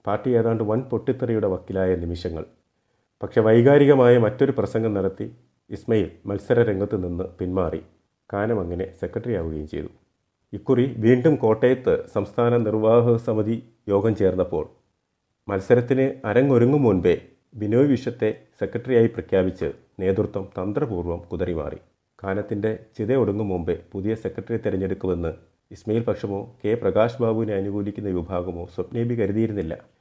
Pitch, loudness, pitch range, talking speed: 110 Hz, -22 LUFS, 95-115 Hz, 105 wpm